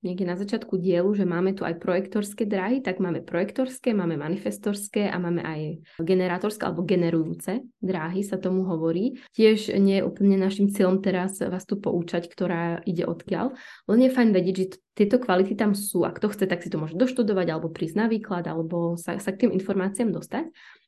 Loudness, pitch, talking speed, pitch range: -25 LUFS, 190 Hz, 190 wpm, 175-210 Hz